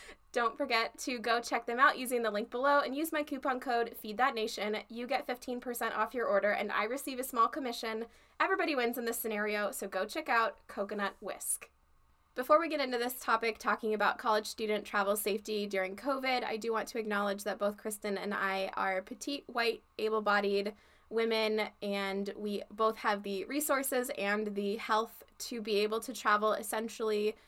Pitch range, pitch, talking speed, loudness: 205-250 Hz, 225 Hz, 190 wpm, -33 LUFS